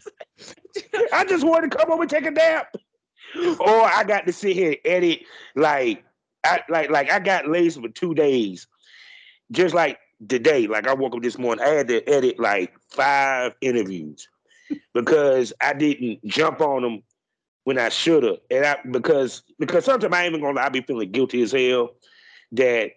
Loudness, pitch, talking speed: -21 LUFS, 175 Hz, 180 wpm